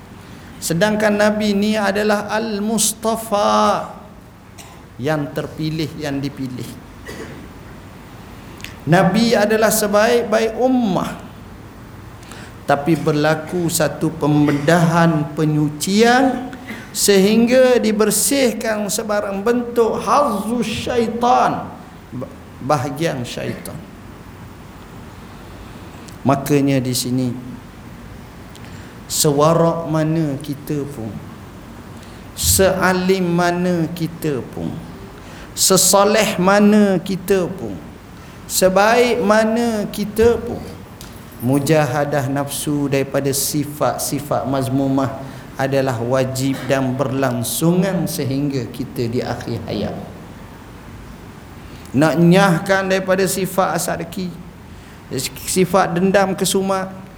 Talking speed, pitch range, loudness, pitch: 70 wpm, 135-205 Hz, -17 LUFS, 160 Hz